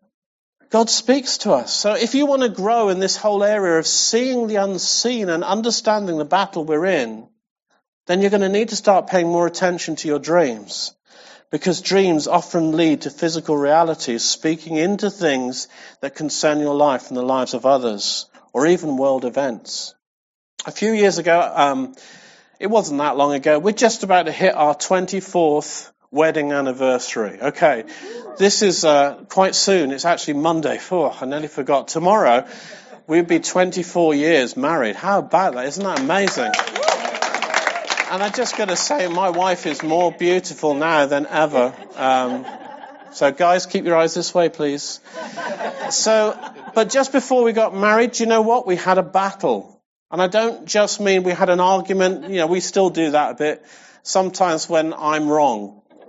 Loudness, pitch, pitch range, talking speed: -18 LUFS, 180 Hz, 155-210 Hz, 175 wpm